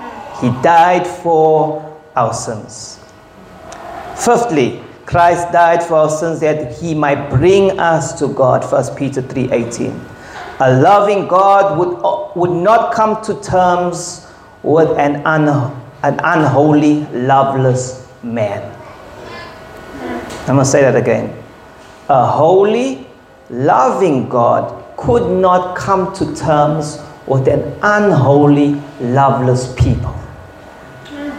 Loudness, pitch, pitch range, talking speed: -13 LUFS, 155 Hz, 135-180 Hz, 105 wpm